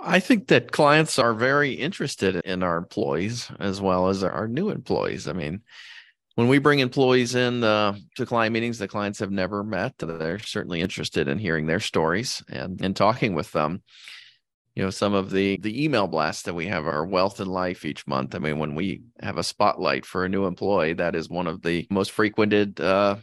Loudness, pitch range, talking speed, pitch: -24 LUFS, 90-115 Hz, 205 wpm, 100 Hz